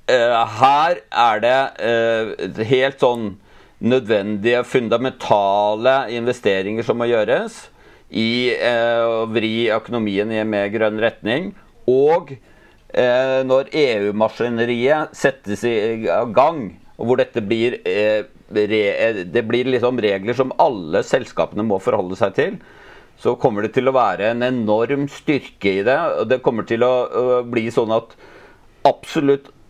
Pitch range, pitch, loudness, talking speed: 110-125 Hz, 115 Hz, -18 LUFS, 125 wpm